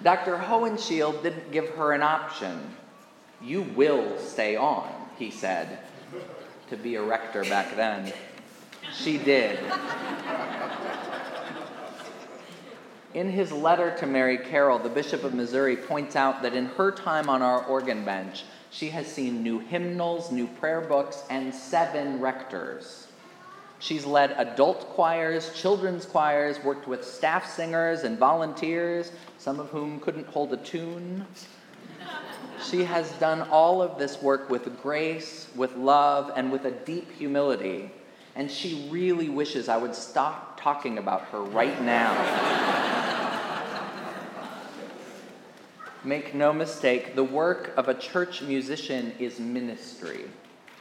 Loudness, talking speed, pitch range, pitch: -27 LUFS, 130 wpm, 135-170 Hz, 150 Hz